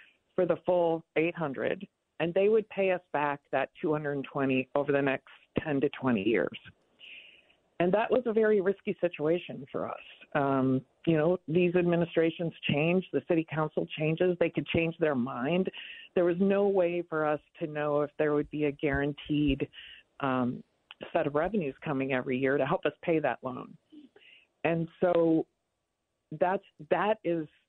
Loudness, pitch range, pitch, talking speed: -30 LUFS, 145-180 Hz, 160 Hz, 165 wpm